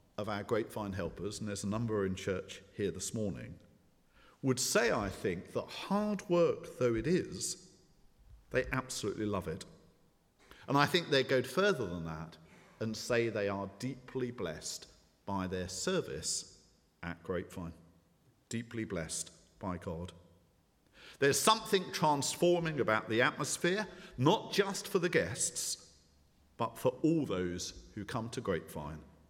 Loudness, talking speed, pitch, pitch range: -34 LUFS, 140 wpm, 110 Hz, 90-145 Hz